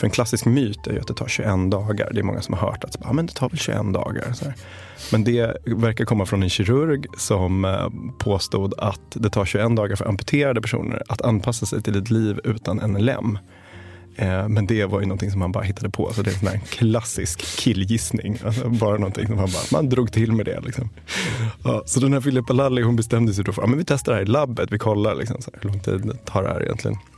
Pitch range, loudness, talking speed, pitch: 100-120 Hz, -22 LUFS, 240 wpm, 110 Hz